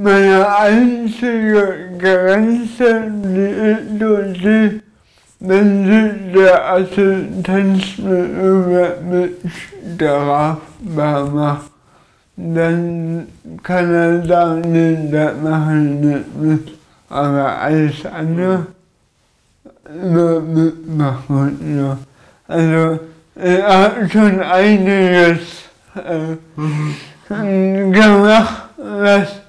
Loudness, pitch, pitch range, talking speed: -14 LUFS, 180 Hz, 160-200 Hz, 85 wpm